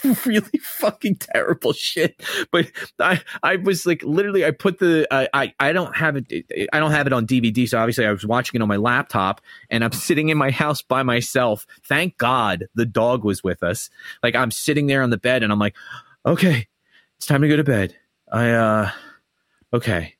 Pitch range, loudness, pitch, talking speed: 115-160 Hz, -20 LUFS, 130 Hz, 205 wpm